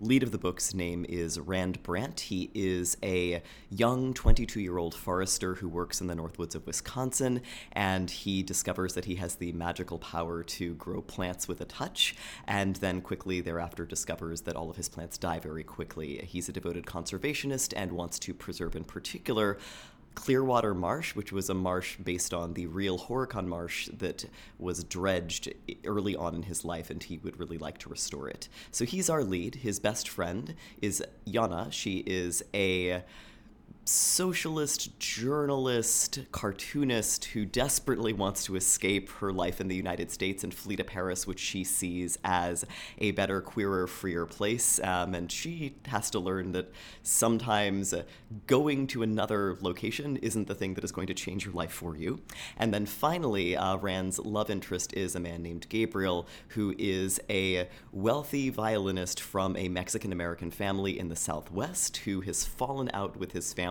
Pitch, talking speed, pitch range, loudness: 95 Hz, 170 wpm, 90-110 Hz, -32 LUFS